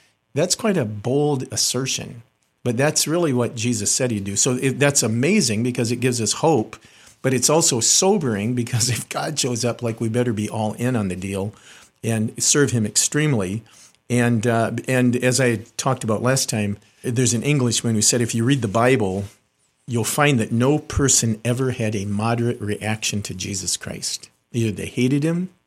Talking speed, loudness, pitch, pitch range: 185 wpm, -20 LUFS, 120 Hz, 110-130 Hz